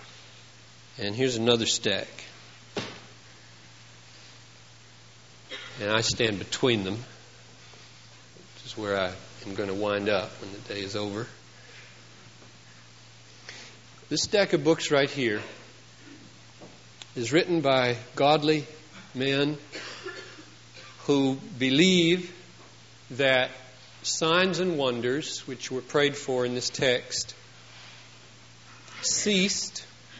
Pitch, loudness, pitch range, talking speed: 125 Hz, -26 LUFS, 115-145 Hz, 95 wpm